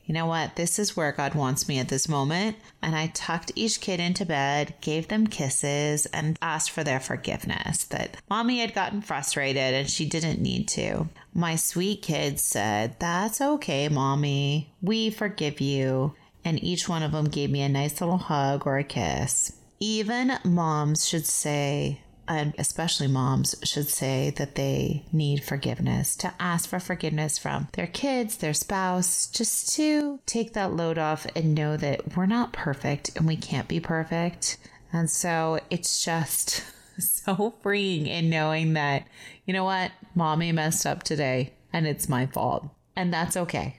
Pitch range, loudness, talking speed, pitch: 145-185 Hz, -26 LUFS, 170 wpm, 160 Hz